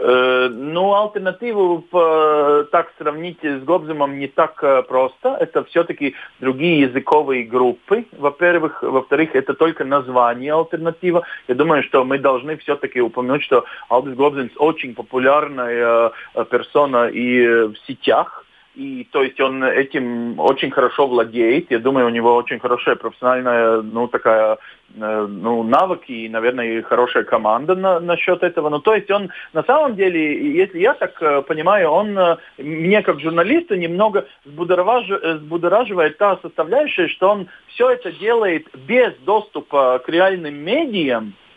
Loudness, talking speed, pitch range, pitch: -17 LUFS, 130 wpm, 125-185 Hz, 150 Hz